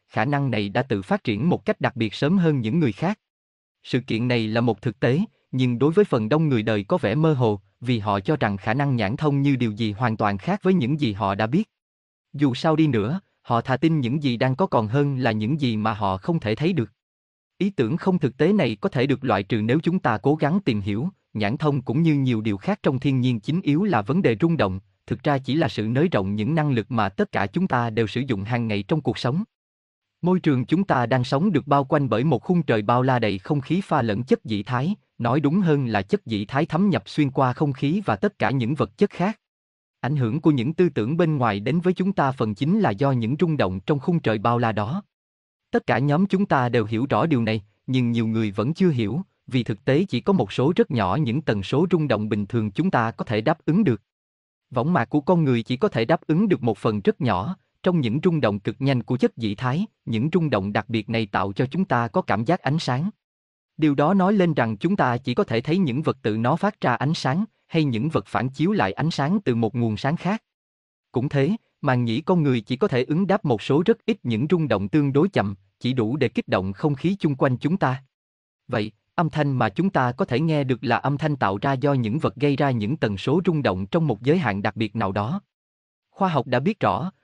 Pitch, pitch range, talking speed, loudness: 135 Hz, 115-160 Hz, 265 wpm, -23 LUFS